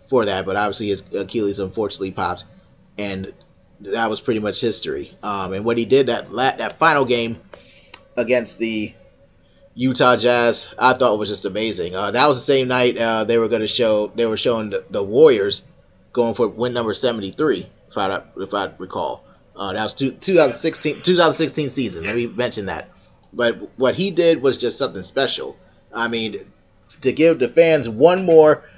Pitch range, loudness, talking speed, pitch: 105-145 Hz, -19 LUFS, 180 wpm, 120 Hz